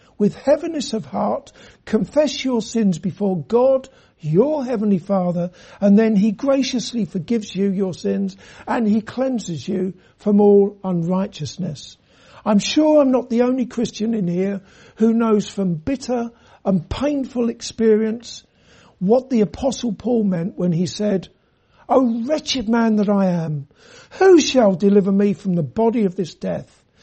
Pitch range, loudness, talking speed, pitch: 190-245 Hz, -19 LUFS, 150 wpm, 210 Hz